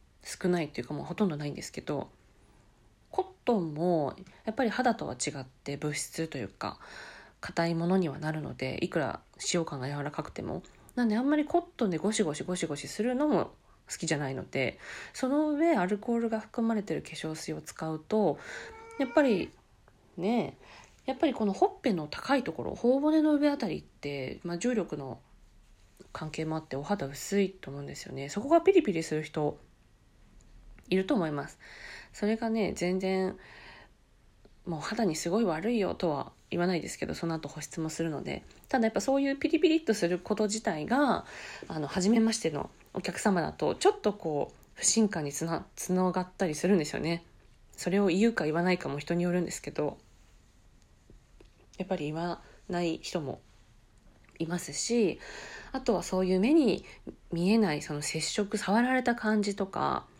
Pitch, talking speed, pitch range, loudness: 185 Hz, 345 characters per minute, 155-225 Hz, -31 LUFS